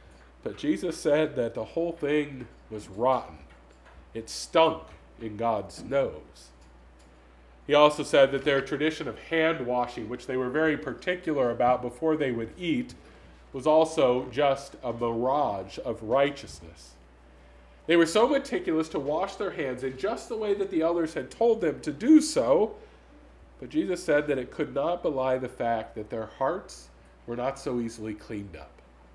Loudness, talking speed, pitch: -27 LUFS, 165 wpm, 130 Hz